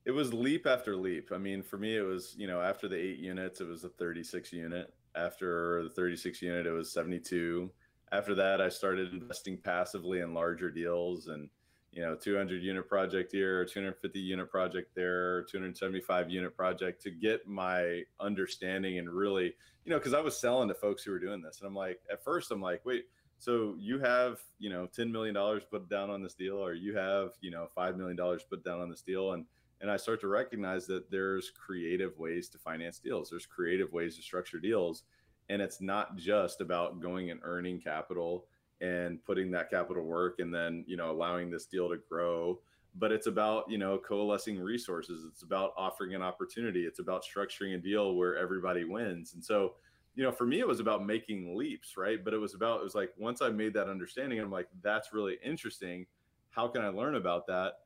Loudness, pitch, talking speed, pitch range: -36 LUFS, 90 Hz, 215 wpm, 90-100 Hz